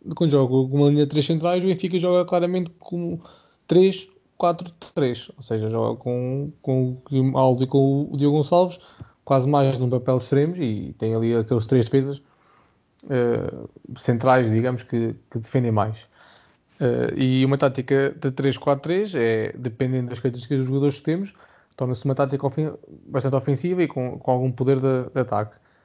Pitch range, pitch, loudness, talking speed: 125-150 Hz, 135 Hz, -22 LUFS, 175 wpm